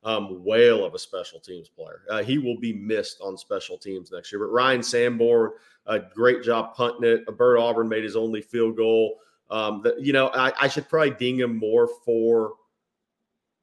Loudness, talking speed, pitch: -23 LUFS, 200 wpm, 125 Hz